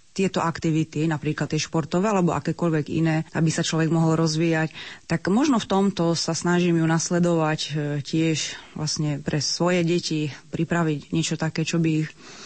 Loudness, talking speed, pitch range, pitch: -23 LUFS, 155 wpm, 155-170 Hz, 160 Hz